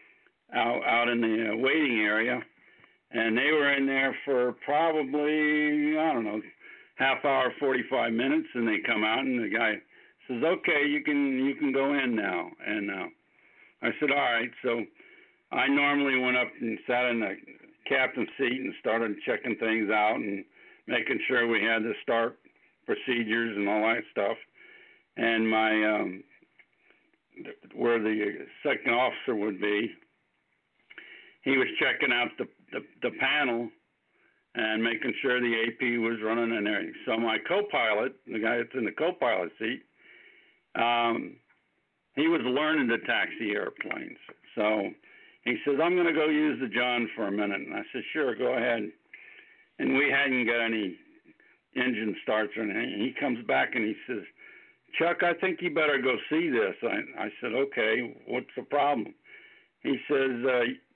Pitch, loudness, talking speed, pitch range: 125 Hz, -28 LUFS, 160 wpm, 115-150 Hz